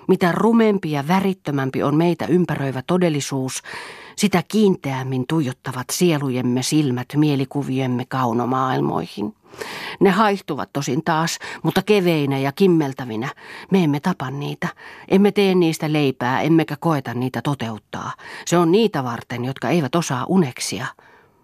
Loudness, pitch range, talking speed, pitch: -20 LUFS, 130-175 Hz, 120 wpm, 150 Hz